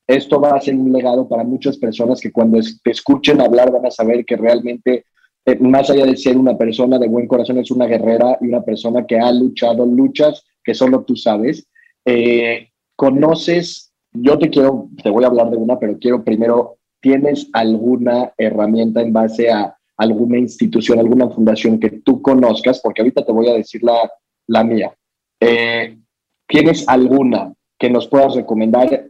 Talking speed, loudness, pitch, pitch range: 175 wpm, -14 LUFS, 120 Hz, 115-130 Hz